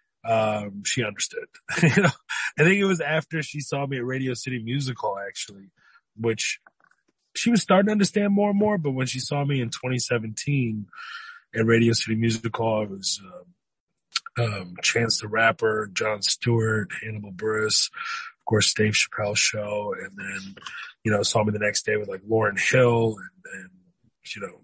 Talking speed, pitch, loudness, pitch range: 175 wpm, 115 Hz, -24 LUFS, 105-140 Hz